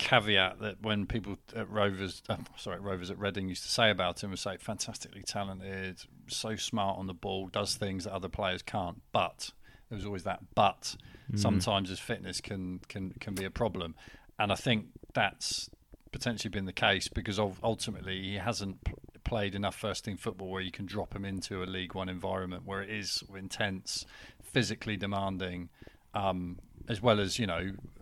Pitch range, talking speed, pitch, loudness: 95-105 Hz, 180 wpm, 100 Hz, -34 LUFS